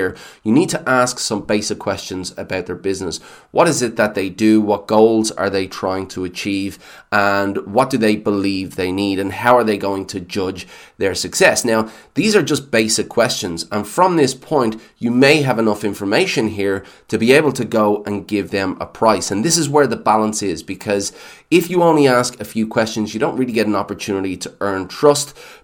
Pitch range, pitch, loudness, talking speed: 95-115 Hz, 105 Hz, -17 LUFS, 210 wpm